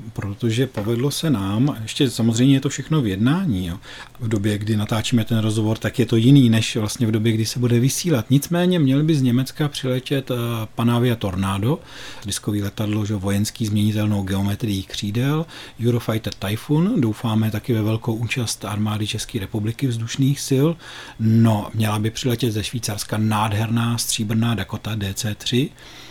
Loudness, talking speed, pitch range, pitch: -21 LUFS, 155 wpm, 105-130 Hz, 115 Hz